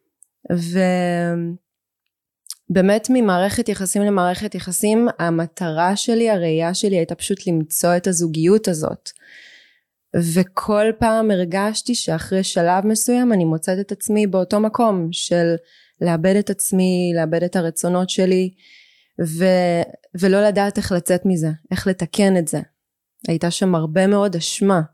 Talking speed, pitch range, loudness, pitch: 120 wpm, 170-205 Hz, -19 LUFS, 185 Hz